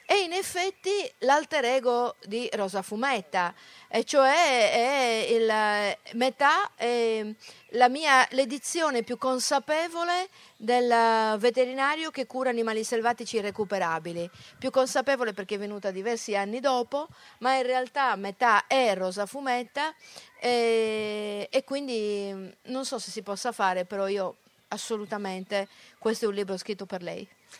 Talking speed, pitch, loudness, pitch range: 130 wpm, 235 Hz, -27 LUFS, 210-270 Hz